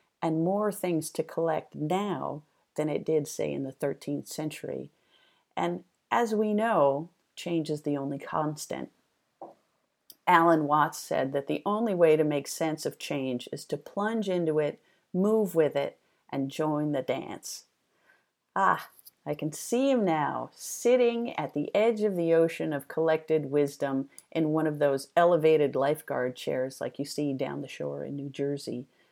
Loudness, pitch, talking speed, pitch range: -29 LUFS, 155 Hz, 165 wpm, 145-175 Hz